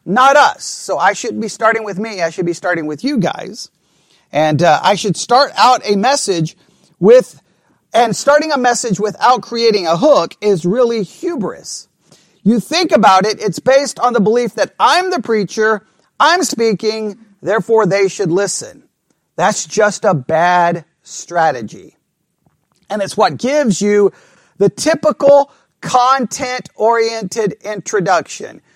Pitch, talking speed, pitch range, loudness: 215 Hz, 145 wpm, 185-245 Hz, -14 LUFS